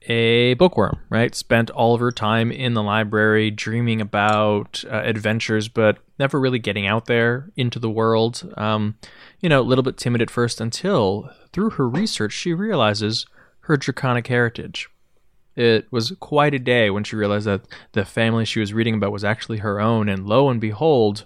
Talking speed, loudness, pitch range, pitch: 185 wpm, -20 LUFS, 110-125 Hz, 115 Hz